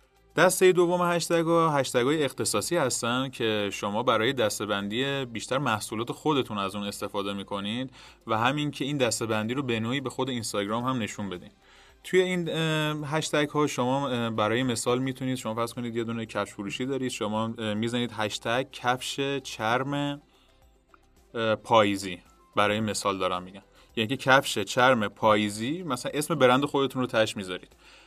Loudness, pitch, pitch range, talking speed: -27 LUFS, 120 Hz, 105-140 Hz, 150 wpm